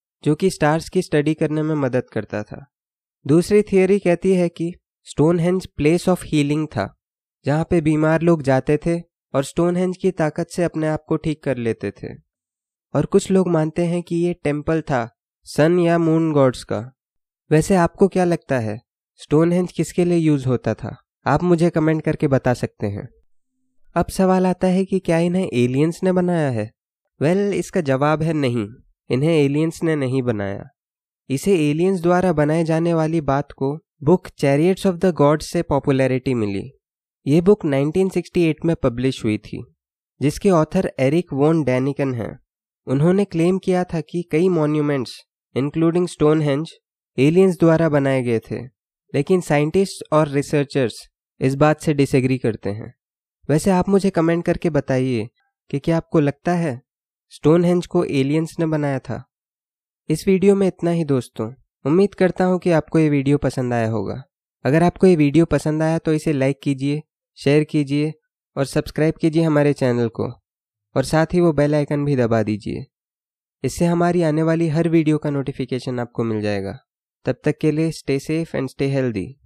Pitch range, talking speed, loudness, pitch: 135-170 Hz, 170 wpm, -19 LUFS, 155 Hz